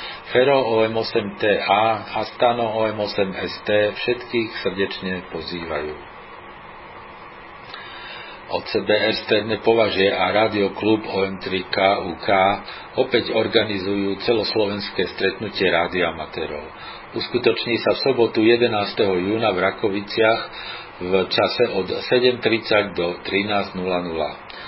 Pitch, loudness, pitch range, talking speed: 100 Hz, -20 LUFS, 95-110 Hz, 80 wpm